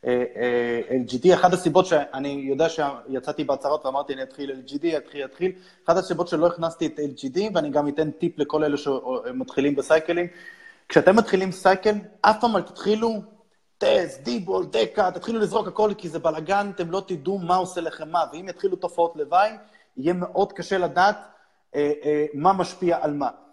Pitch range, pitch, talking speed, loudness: 145-195 Hz, 175 Hz, 155 wpm, -23 LUFS